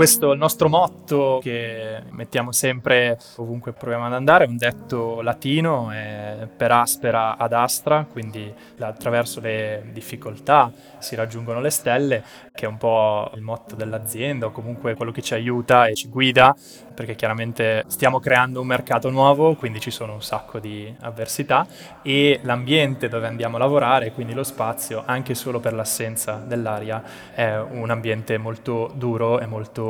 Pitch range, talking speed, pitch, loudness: 110-130 Hz, 160 wpm, 120 Hz, -21 LUFS